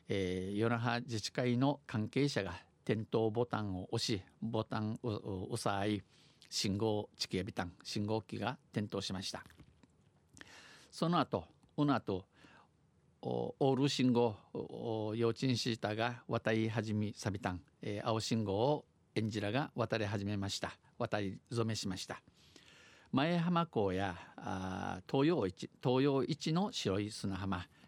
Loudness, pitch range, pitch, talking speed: -37 LUFS, 100-120 Hz, 110 Hz, 240 characters per minute